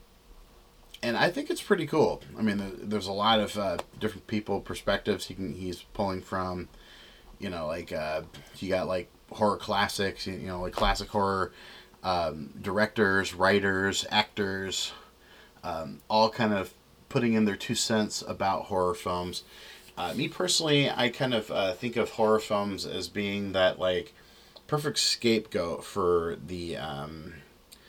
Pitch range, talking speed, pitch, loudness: 90-110 Hz, 155 wpm, 100 Hz, -29 LUFS